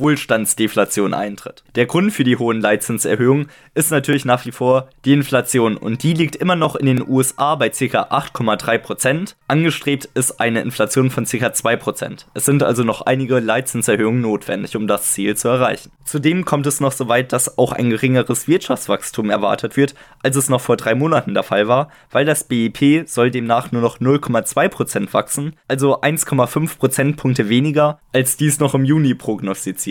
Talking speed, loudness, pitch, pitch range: 175 wpm, -17 LUFS, 130 Hz, 120-145 Hz